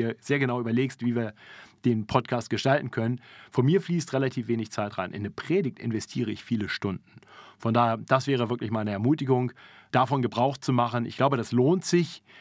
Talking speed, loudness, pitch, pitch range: 190 wpm, -27 LUFS, 120 Hz, 115-135 Hz